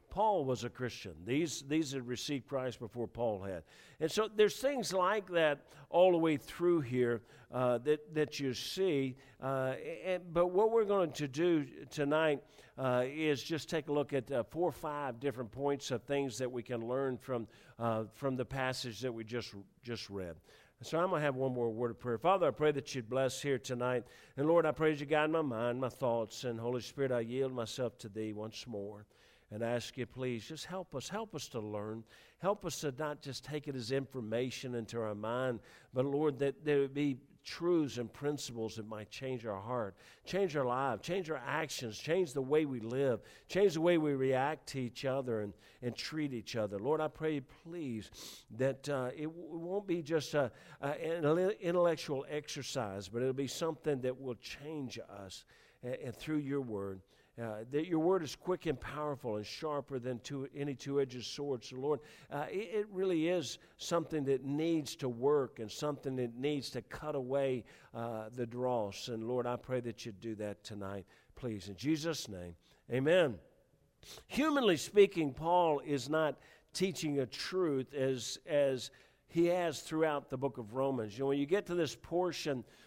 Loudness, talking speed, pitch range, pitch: -36 LUFS, 200 wpm, 120-155 Hz, 135 Hz